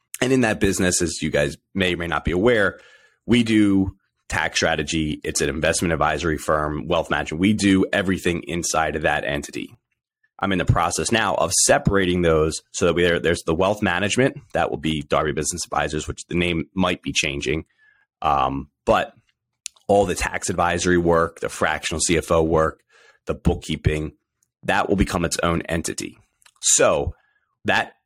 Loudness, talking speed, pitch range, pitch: -21 LUFS, 170 wpm, 80-95 Hz, 85 Hz